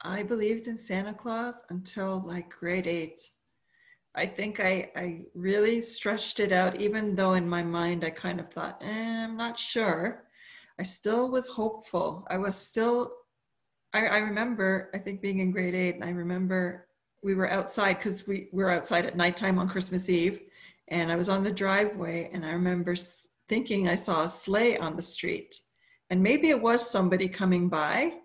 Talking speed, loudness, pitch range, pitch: 180 wpm, -29 LUFS, 180-220 Hz, 190 Hz